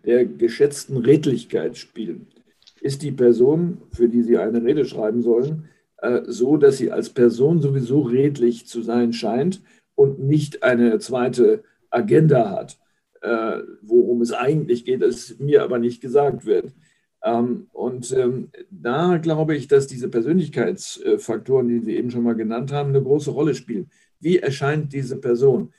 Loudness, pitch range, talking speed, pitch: -20 LUFS, 120-175 Hz, 145 wpm, 140 Hz